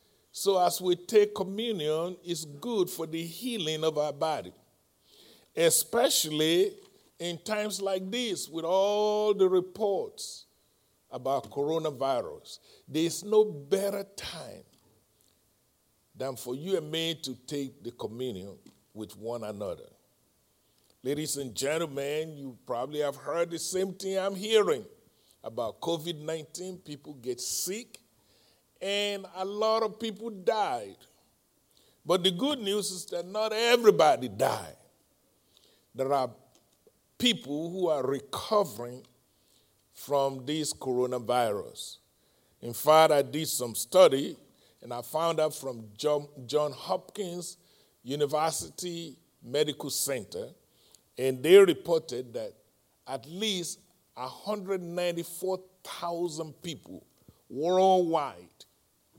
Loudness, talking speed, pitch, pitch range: -29 LUFS, 105 wpm, 170 Hz, 145-200 Hz